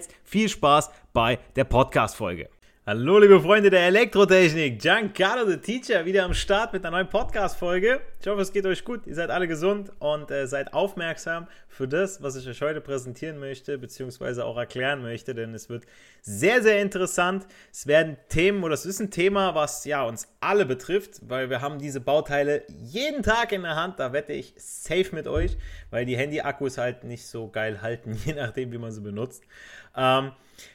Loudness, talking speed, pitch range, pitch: -24 LUFS, 190 wpm, 130-190 Hz, 155 Hz